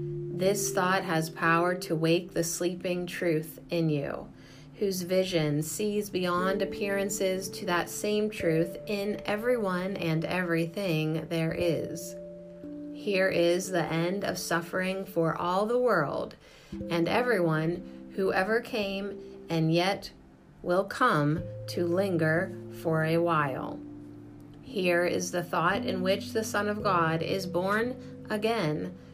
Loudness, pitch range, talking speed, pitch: -29 LUFS, 160-195 Hz, 130 wpm, 175 Hz